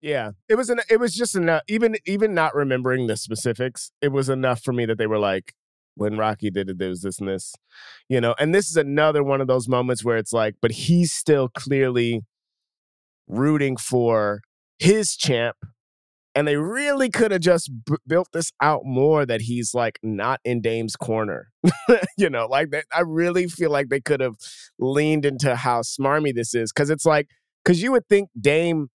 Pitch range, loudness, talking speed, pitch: 115-160 Hz, -22 LUFS, 200 wpm, 135 Hz